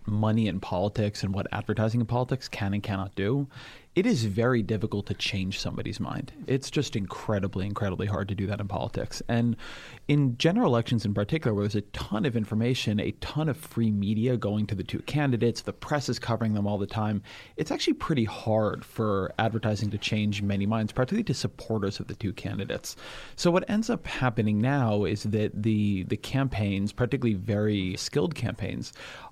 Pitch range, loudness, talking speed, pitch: 105-120 Hz, -28 LUFS, 190 wpm, 110 Hz